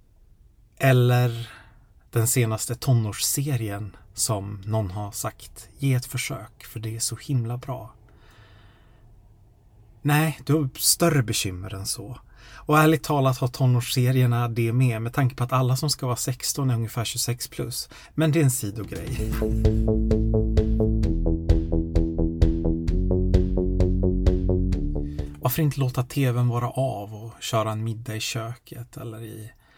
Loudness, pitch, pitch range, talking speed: -24 LUFS, 115 Hz, 105-125 Hz, 125 wpm